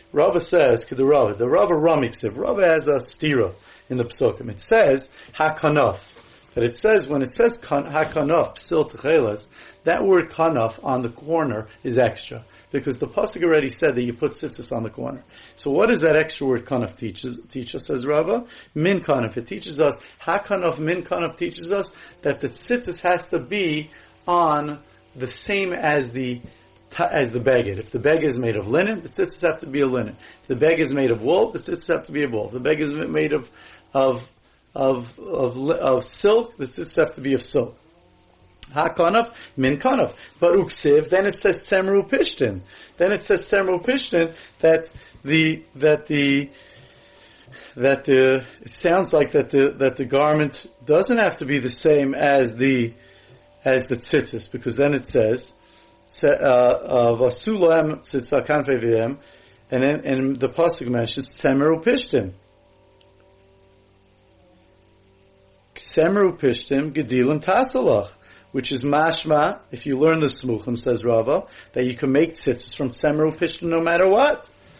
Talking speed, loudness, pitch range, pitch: 160 wpm, -21 LUFS, 125-165 Hz, 140 Hz